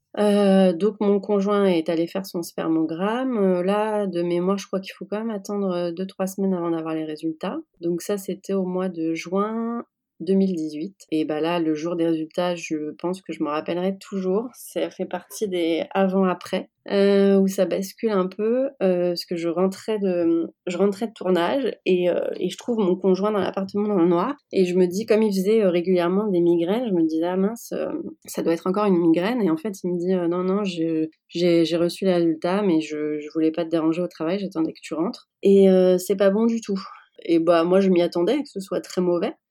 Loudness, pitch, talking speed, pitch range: -23 LUFS, 185 Hz, 225 wpm, 170-200 Hz